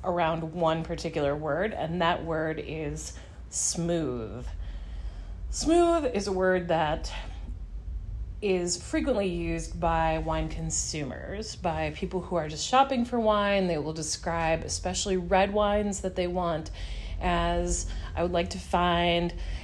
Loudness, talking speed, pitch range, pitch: -28 LUFS, 130 wpm, 145-185 Hz, 165 Hz